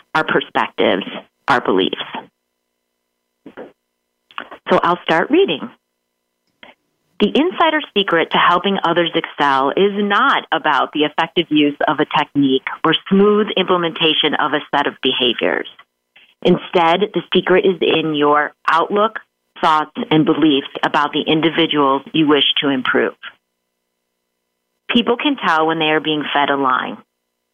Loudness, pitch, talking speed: -16 LUFS, 150 Hz, 130 wpm